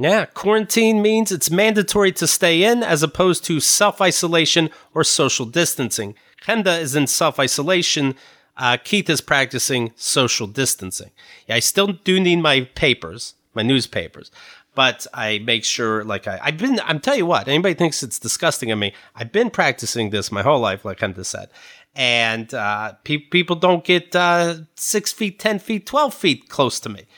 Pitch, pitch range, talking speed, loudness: 160 Hz, 120-185 Hz, 175 wpm, -18 LUFS